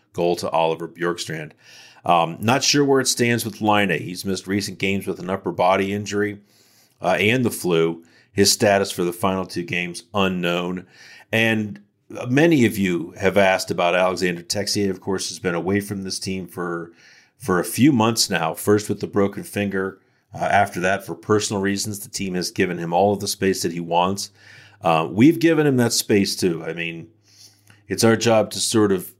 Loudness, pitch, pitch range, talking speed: -20 LUFS, 100 Hz, 90-105 Hz, 195 wpm